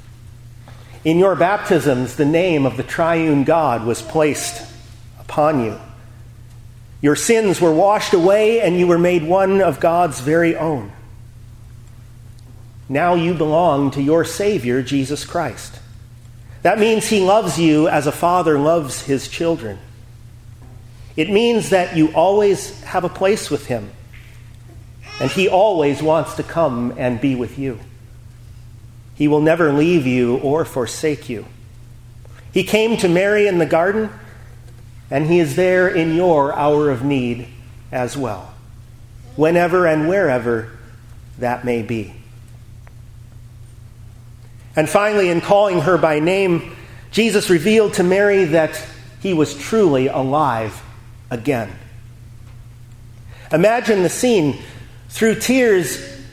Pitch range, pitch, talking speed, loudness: 115-170 Hz, 135 Hz, 130 wpm, -17 LUFS